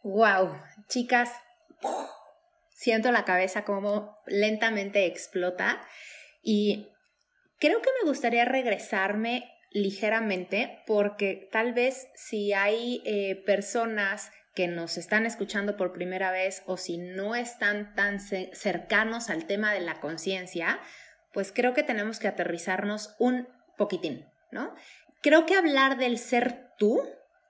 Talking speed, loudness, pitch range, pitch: 120 wpm, -28 LUFS, 195-245 Hz, 210 Hz